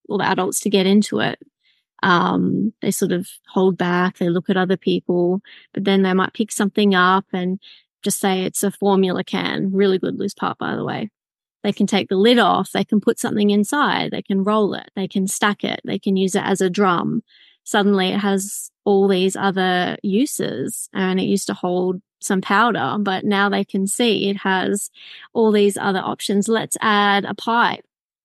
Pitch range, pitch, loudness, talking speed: 190-205 Hz, 195 Hz, -19 LUFS, 200 wpm